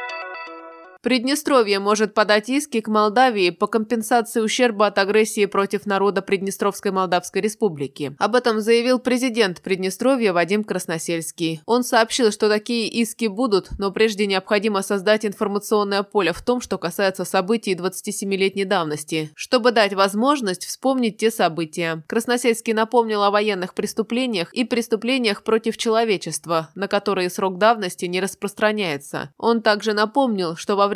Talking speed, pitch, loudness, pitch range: 135 wpm, 210 Hz, -20 LUFS, 190-230 Hz